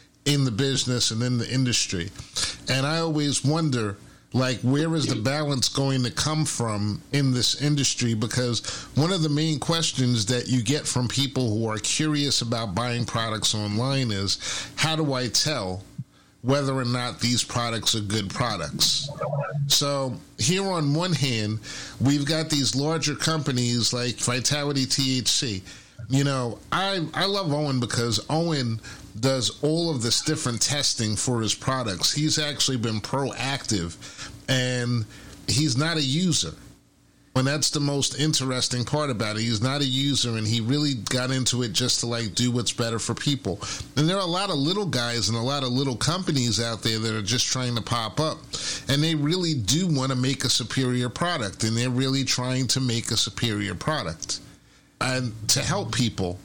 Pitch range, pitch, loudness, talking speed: 115-145 Hz, 130 Hz, -24 LUFS, 175 wpm